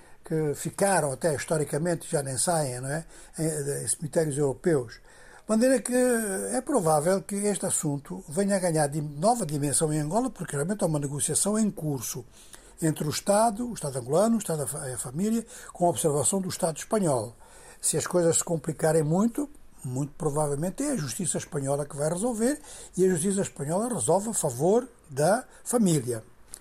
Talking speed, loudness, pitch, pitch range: 165 wpm, -27 LUFS, 170 Hz, 150-200 Hz